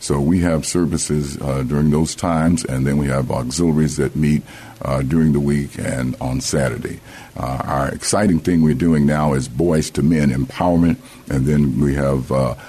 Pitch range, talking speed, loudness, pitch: 70-80 Hz, 185 wpm, -18 LUFS, 75 Hz